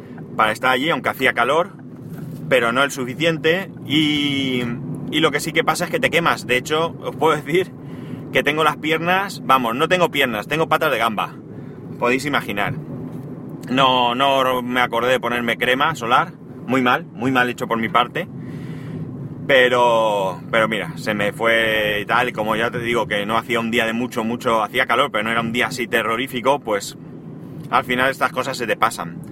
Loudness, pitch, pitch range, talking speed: -19 LUFS, 125 Hz, 115-140 Hz, 190 wpm